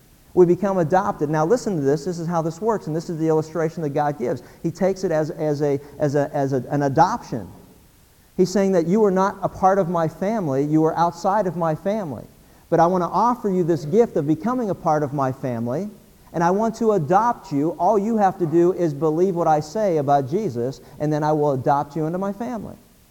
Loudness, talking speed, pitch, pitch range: -21 LUFS, 235 wpm, 170 Hz, 150-195 Hz